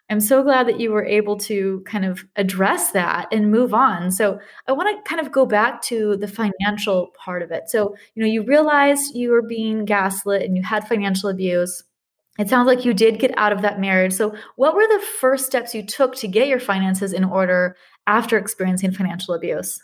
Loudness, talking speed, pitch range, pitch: -19 LUFS, 215 wpm, 195-245 Hz, 210 Hz